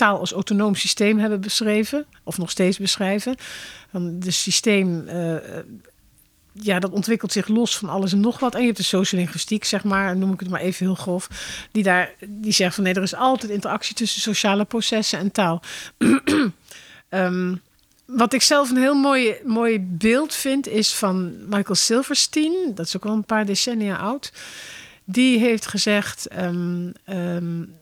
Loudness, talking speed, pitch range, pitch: -21 LUFS, 170 wpm, 185-230 Hz, 205 Hz